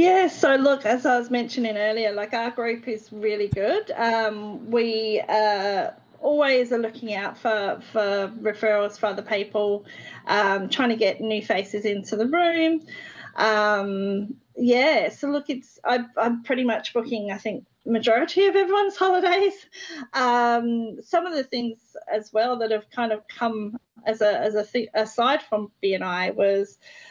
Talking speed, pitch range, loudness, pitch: 165 wpm, 210-250 Hz, -23 LUFS, 225 Hz